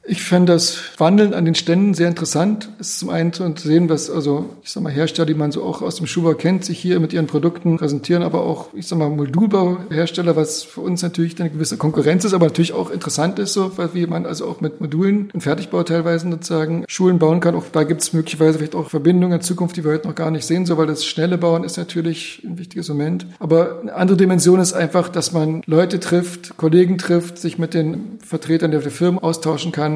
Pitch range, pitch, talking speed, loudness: 160-180 Hz, 170 Hz, 230 wpm, -18 LUFS